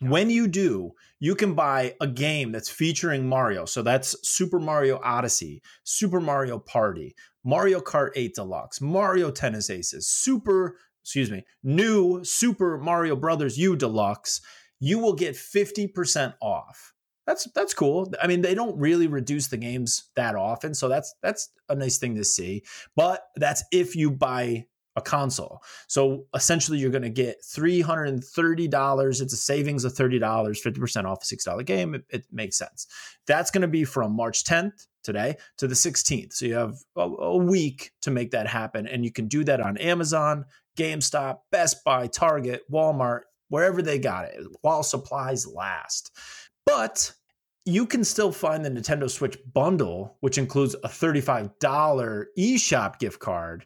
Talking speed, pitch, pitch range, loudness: 160 wpm, 145 Hz, 125-175 Hz, -25 LUFS